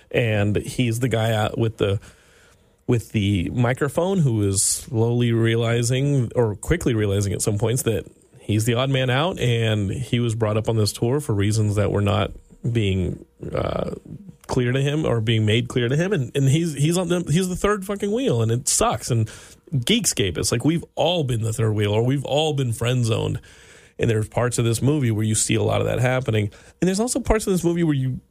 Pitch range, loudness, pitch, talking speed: 110-145 Hz, -22 LUFS, 120 Hz, 220 wpm